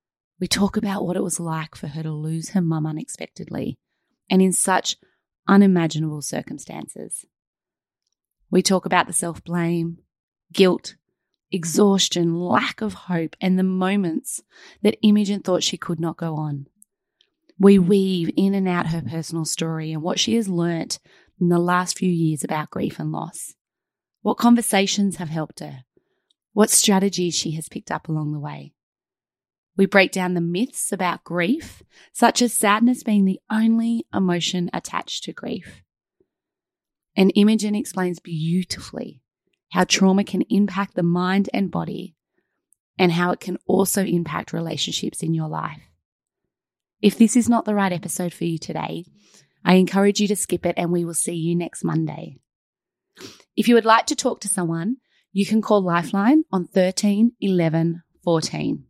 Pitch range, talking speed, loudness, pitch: 170-205 Hz, 160 wpm, -21 LUFS, 185 Hz